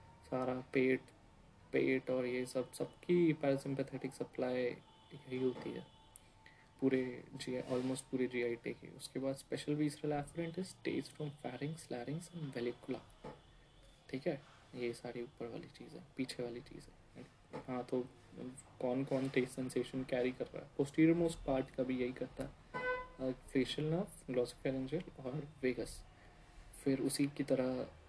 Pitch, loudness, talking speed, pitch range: 130 Hz, -40 LUFS, 145 wpm, 125-145 Hz